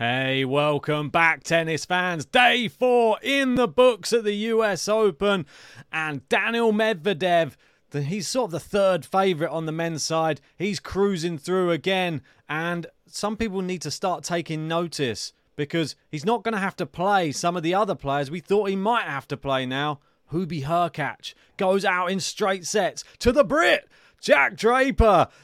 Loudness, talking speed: -23 LUFS, 175 wpm